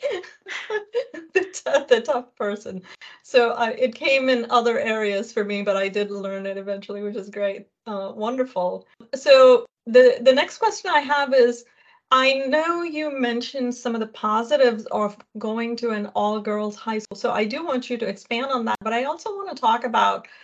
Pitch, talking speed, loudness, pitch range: 240 Hz, 190 wpm, -22 LUFS, 215-290 Hz